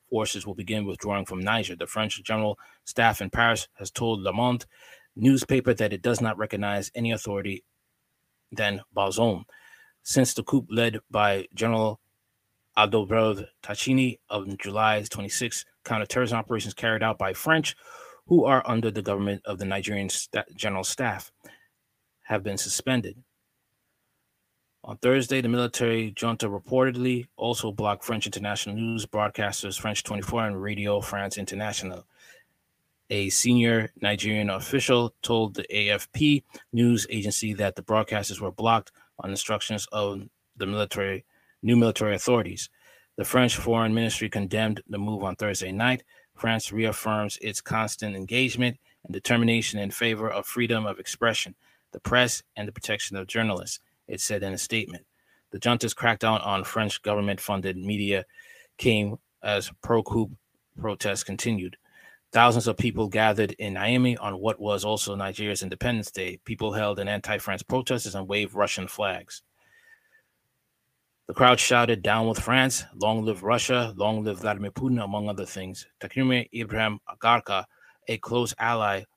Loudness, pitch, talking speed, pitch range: -26 LUFS, 110 Hz, 145 wpm, 100-120 Hz